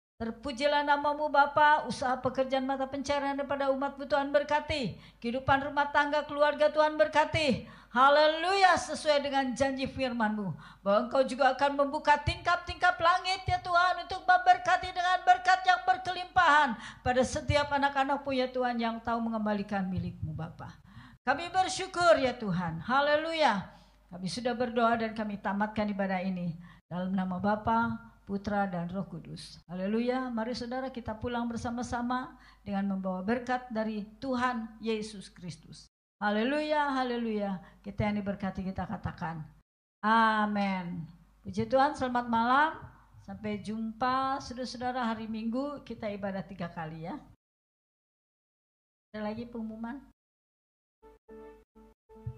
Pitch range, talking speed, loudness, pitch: 205-285 Hz, 120 wpm, -30 LUFS, 245 Hz